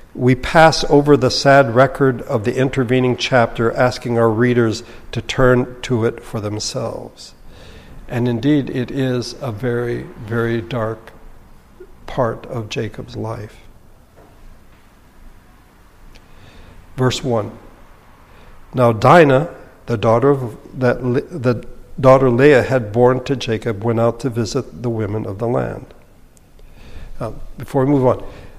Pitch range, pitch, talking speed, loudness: 115-130 Hz, 120 Hz, 130 wpm, -17 LUFS